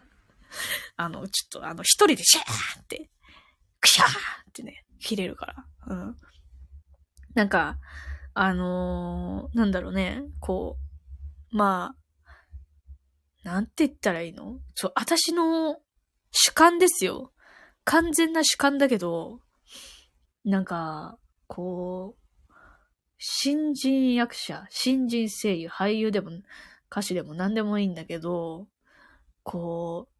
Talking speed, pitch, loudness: 215 characters per minute, 180 Hz, -24 LUFS